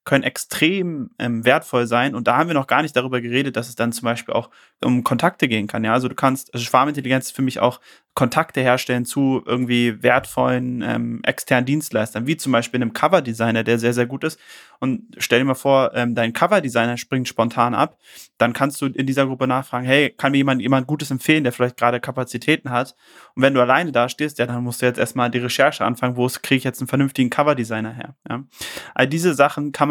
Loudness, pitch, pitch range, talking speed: -19 LUFS, 125 Hz, 120-140 Hz, 225 wpm